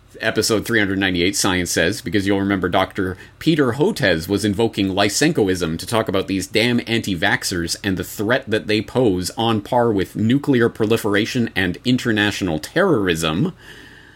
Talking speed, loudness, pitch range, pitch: 145 wpm, -19 LUFS, 95-115 Hz, 105 Hz